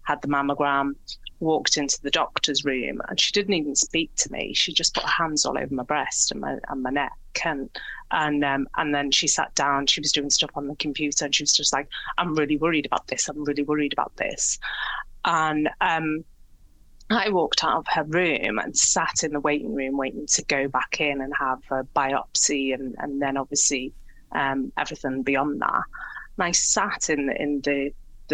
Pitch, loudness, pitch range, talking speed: 145 Hz, -23 LUFS, 135-150 Hz, 205 wpm